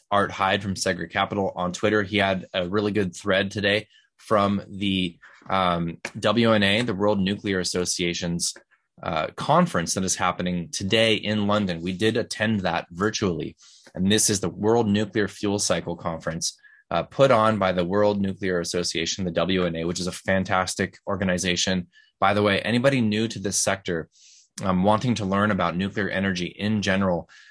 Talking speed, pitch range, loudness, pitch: 165 wpm, 90-105 Hz, -24 LUFS, 95 Hz